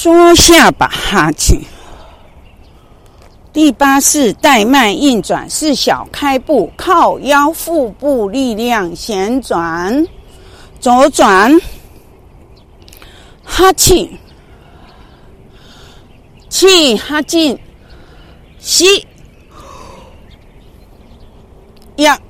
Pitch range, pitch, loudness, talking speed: 255-335 Hz, 290 Hz, -10 LUFS, 90 characters per minute